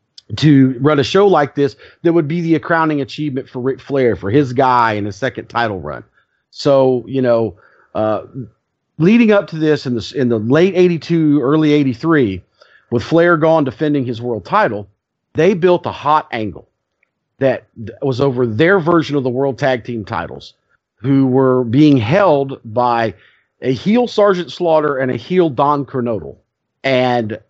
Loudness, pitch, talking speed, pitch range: -15 LUFS, 135 Hz, 170 wpm, 120-155 Hz